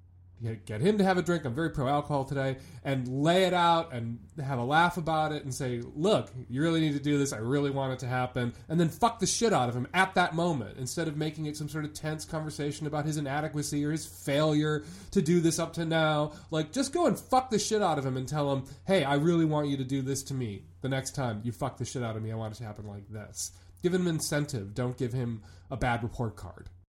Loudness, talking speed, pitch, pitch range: -30 LUFS, 260 wpm, 145 Hz, 125-160 Hz